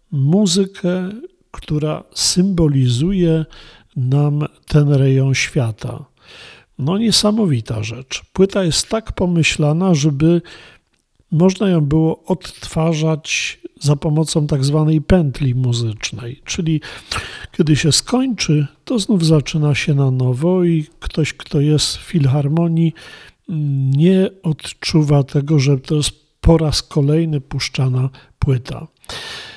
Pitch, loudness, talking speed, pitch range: 155 Hz, -17 LUFS, 105 wpm, 140-175 Hz